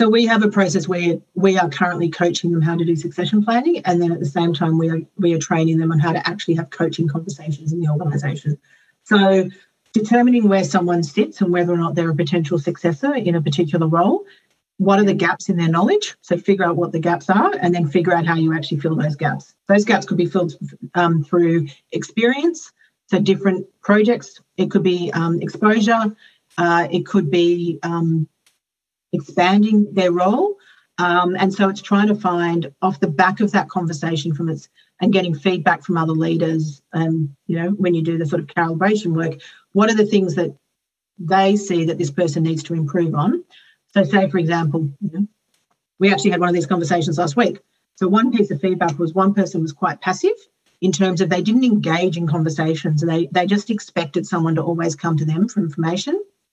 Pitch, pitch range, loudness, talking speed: 175 Hz, 165-195 Hz, -18 LUFS, 210 wpm